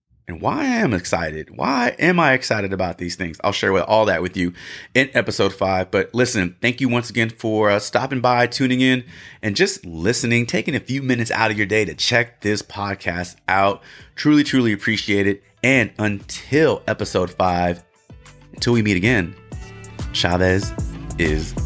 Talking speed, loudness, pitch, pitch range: 170 wpm, -19 LUFS, 105 Hz, 95-120 Hz